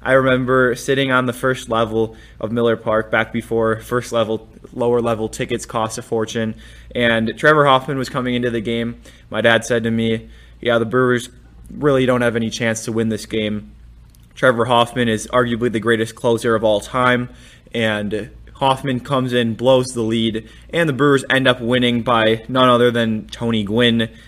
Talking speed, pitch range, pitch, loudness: 185 wpm, 110-125 Hz, 115 Hz, -18 LUFS